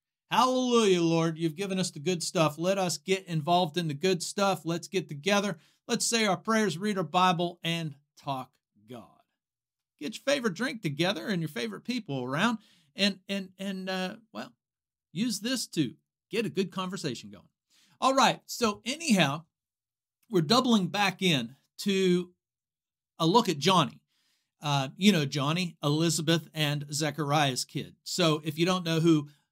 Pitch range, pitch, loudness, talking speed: 155-200 Hz, 180 Hz, -28 LUFS, 160 wpm